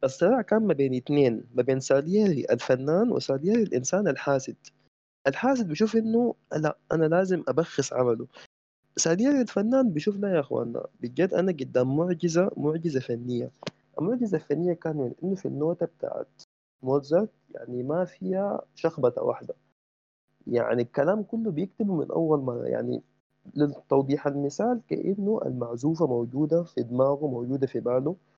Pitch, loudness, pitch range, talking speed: 160 Hz, -27 LUFS, 135-195 Hz, 135 wpm